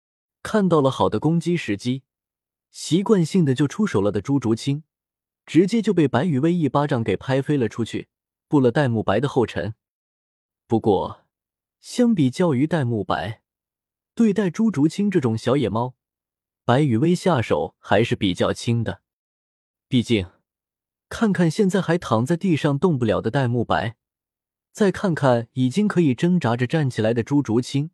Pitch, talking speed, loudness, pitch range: 135 Hz, 235 characters per minute, -21 LUFS, 110-170 Hz